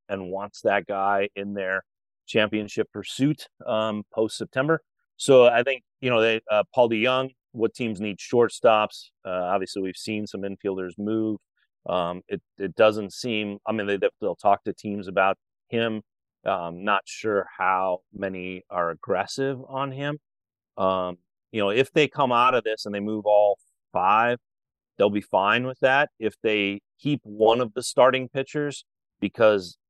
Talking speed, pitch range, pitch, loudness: 165 wpm, 100-125 Hz, 110 Hz, -24 LUFS